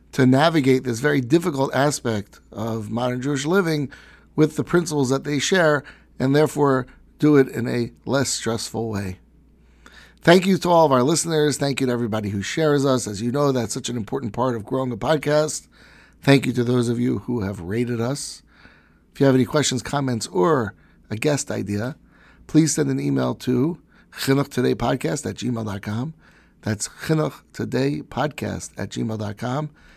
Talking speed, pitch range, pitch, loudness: 165 wpm, 115-145 Hz, 130 Hz, -21 LUFS